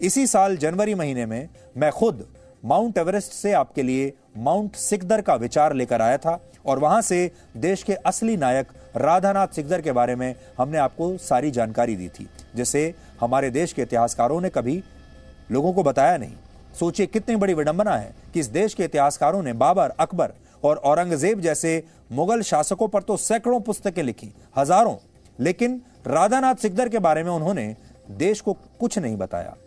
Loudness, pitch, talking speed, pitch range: -22 LUFS, 165 Hz, 170 wpm, 130-200 Hz